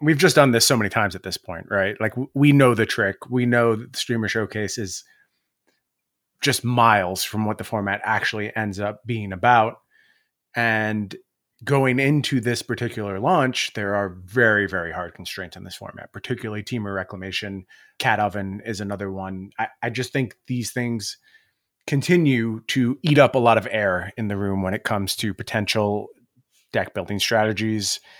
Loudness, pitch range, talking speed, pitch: -22 LUFS, 100-125 Hz, 175 wpm, 110 Hz